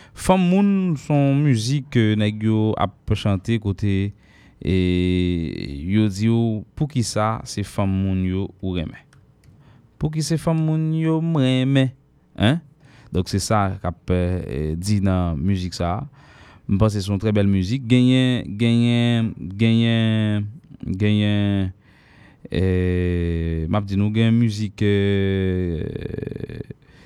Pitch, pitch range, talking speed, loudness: 105 Hz, 95-130 Hz, 125 wpm, -21 LUFS